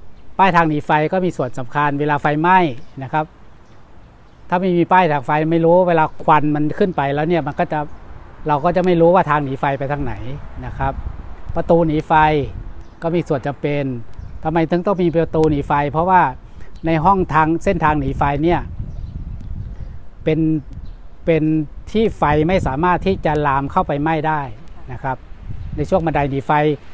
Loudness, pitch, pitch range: -17 LUFS, 150 Hz, 135-170 Hz